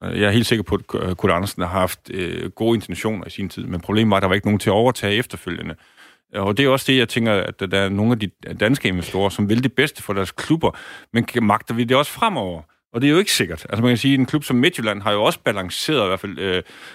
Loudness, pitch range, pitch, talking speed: -20 LUFS, 95-120 Hz, 105 Hz, 280 wpm